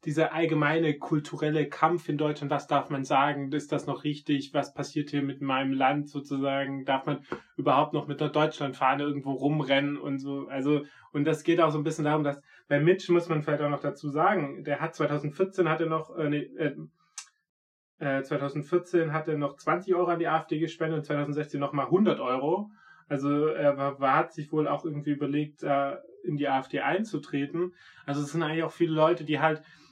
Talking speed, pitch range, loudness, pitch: 195 wpm, 140-160 Hz, -28 LUFS, 150 Hz